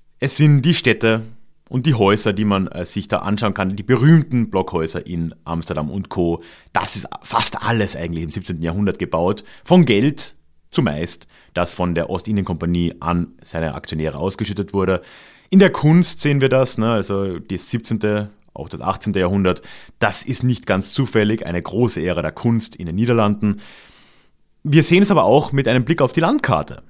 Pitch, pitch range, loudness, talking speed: 105 Hz, 90-125 Hz, -18 LUFS, 175 wpm